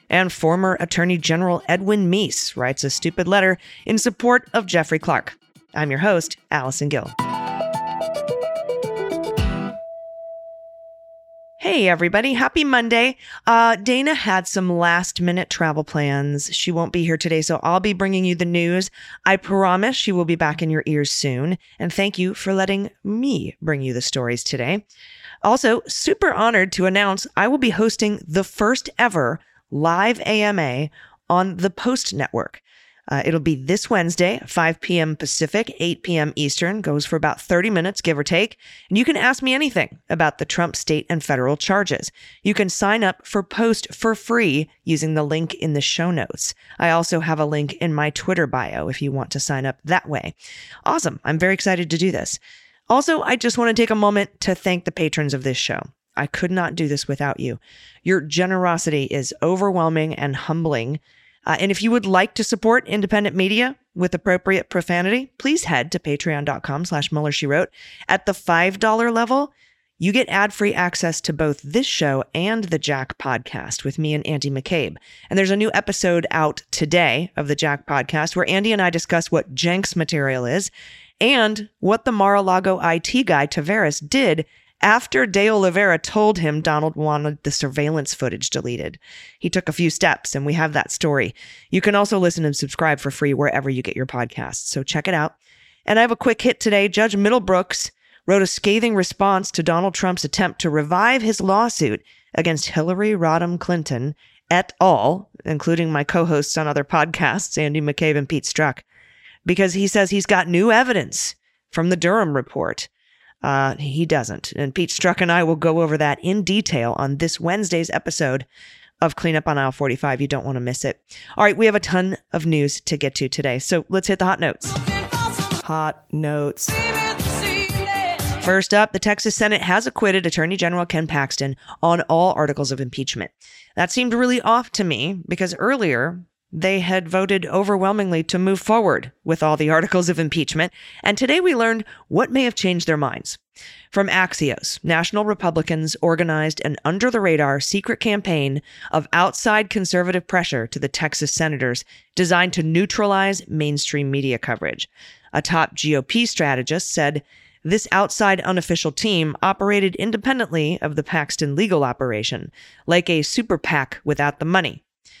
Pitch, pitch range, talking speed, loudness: 175 Hz, 150-205 Hz, 175 wpm, -20 LUFS